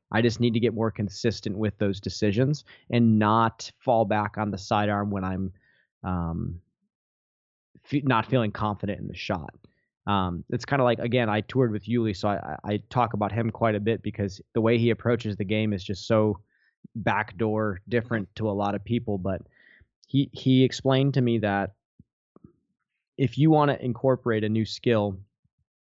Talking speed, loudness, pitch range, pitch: 180 wpm, -26 LUFS, 100-120 Hz, 110 Hz